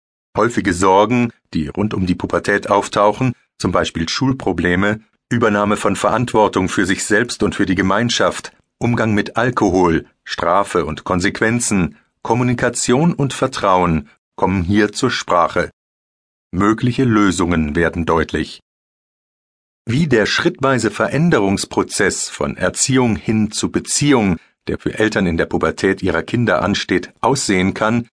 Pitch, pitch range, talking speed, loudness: 105 Hz, 95-120 Hz, 125 wpm, -17 LUFS